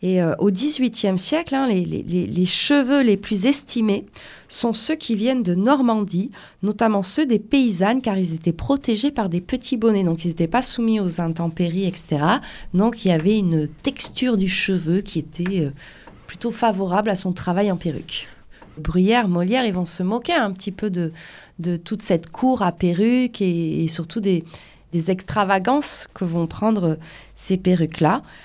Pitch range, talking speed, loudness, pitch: 175-230 Hz, 175 wpm, -21 LUFS, 195 Hz